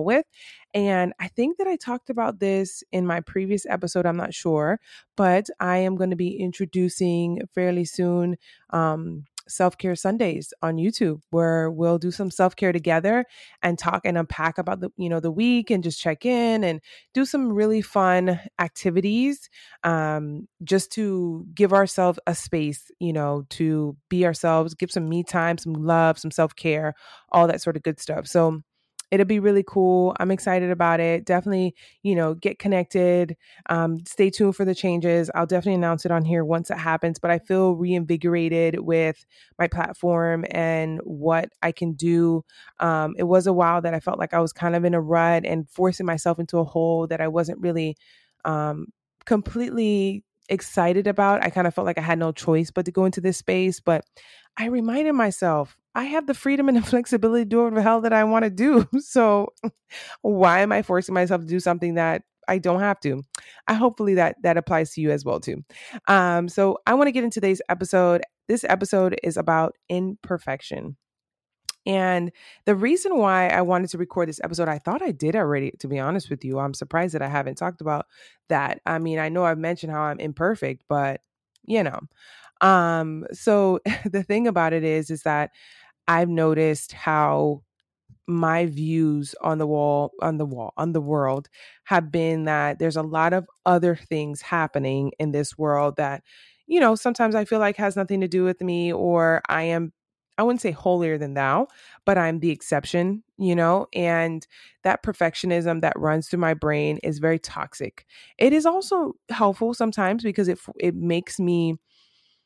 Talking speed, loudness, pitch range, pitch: 190 wpm, -23 LUFS, 165-195 Hz, 175 Hz